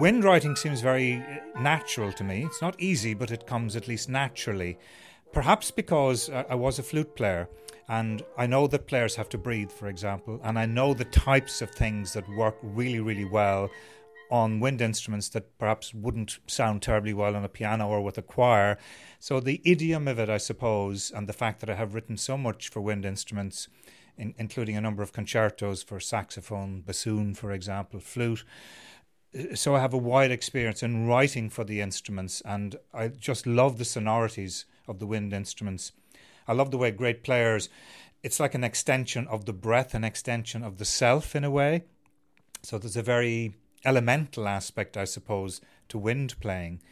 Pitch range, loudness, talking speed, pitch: 105-125 Hz, -28 LUFS, 185 wpm, 115 Hz